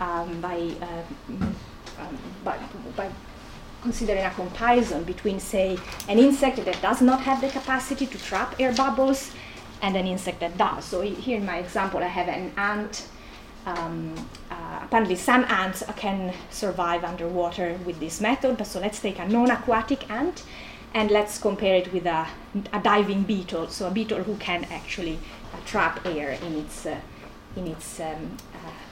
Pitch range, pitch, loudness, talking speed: 180-230 Hz, 195 Hz, -26 LUFS, 170 wpm